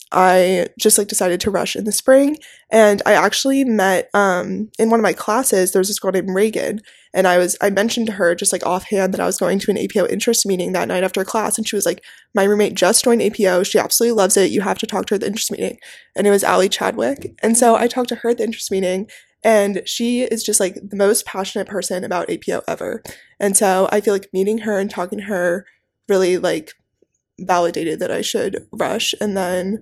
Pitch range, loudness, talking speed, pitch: 185-220 Hz, -17 LUFS, 235 wpm, 200 Hz